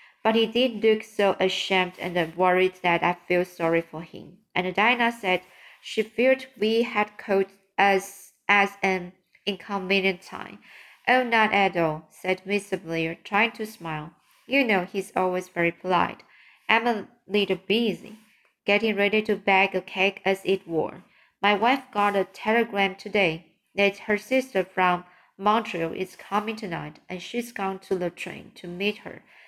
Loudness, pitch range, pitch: -24 LUFS, 180-215 Hz, 195 Hz